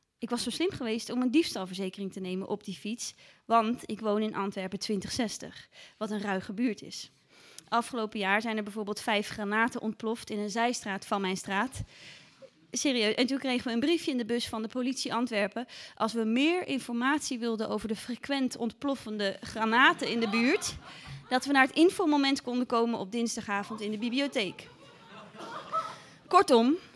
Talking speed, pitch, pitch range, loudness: 175 wpm, 230 Hz, 210-255 Hz, -30 LUFS